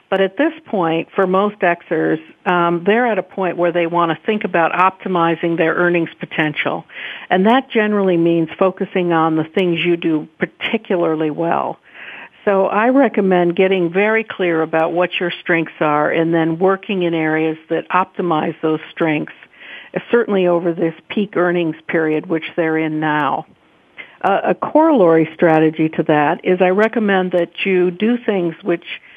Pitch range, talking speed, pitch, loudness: 165-195 Hz, 160 wpm, 175 Hz, -16 LUFS